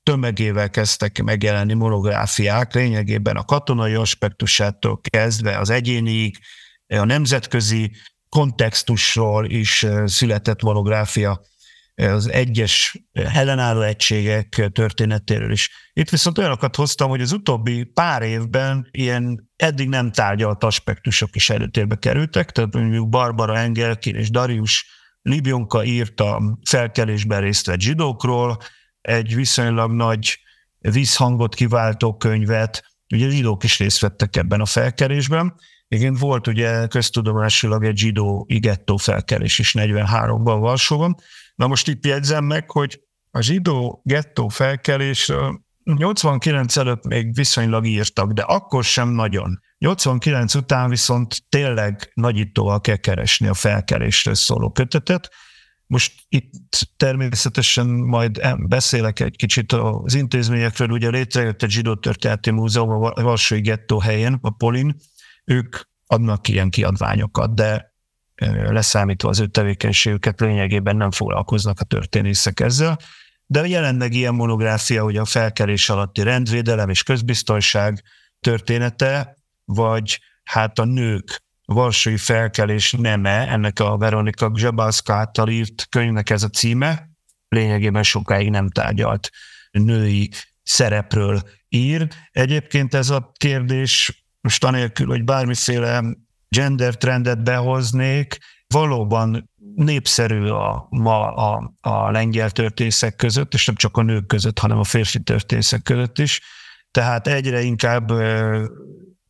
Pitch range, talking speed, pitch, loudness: 105-130 Hz, 120 wpm, 115 Hz, -18 LUFS